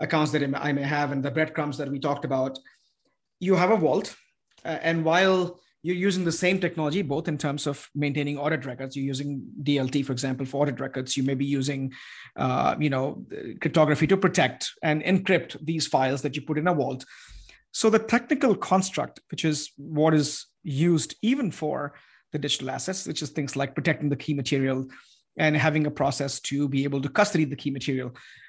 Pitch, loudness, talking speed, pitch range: 150 Hz, -26 LUFS, 195 wpm, 140-165 Hz